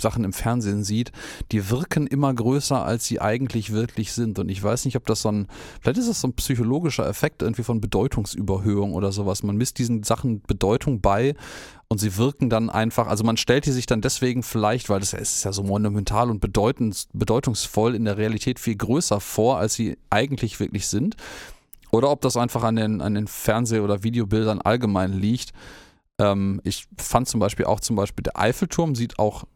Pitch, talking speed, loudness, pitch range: 115 Hz, 195 wpm, -23 LUFS, 105-125 Hz